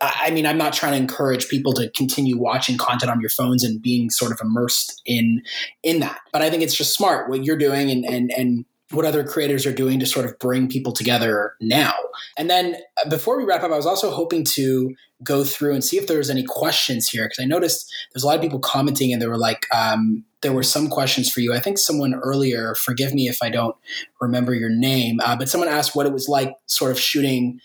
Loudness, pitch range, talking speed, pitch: -20 LUFS, 120-145 Hz, 240 wpm, 130 Hz